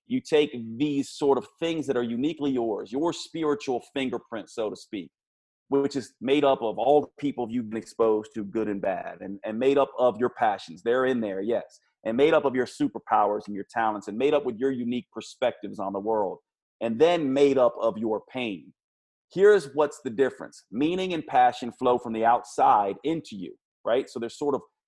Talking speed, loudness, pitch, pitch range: 205 wpm, -26 LUFS, 130 Hz, 115-150 Hz